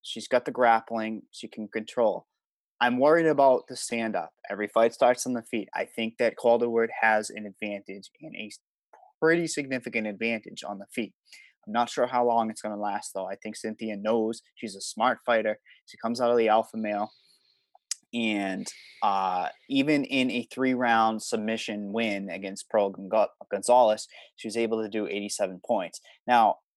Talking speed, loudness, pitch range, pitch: 180 wpm, -27 LUFS, 105-120 Hz, 110 Hz